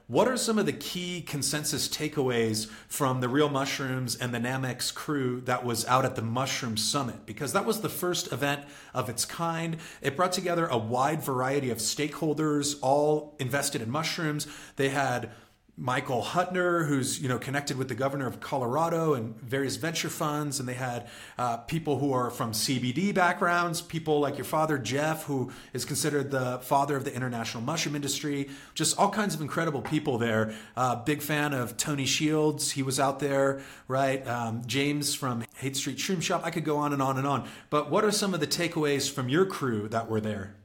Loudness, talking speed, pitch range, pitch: -29 LUFS, 195 wpm, 125-155 Hz, 140 Hz